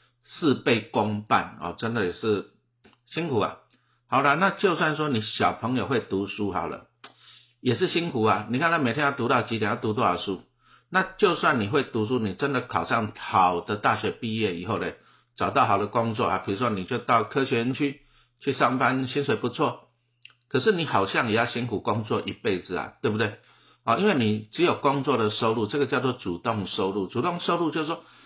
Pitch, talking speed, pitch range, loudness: 120 Hz, 295 characters per minute, 105-140 Hz, -25 LUFS